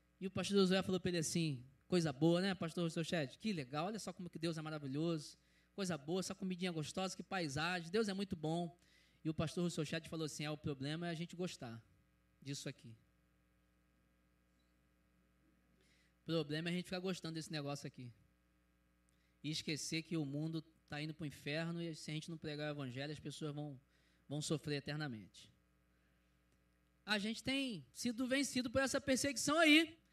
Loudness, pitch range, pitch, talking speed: -40 LUFS, 115-180 Hz, 155 Hz, 185 wpm